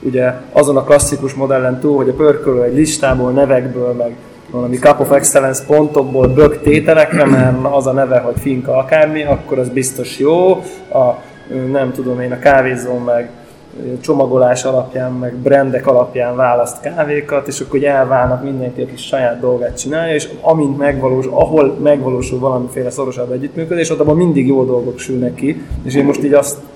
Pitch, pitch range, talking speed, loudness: 135 Hz, 125-145 Hz, 170 wpm, -13 LUFS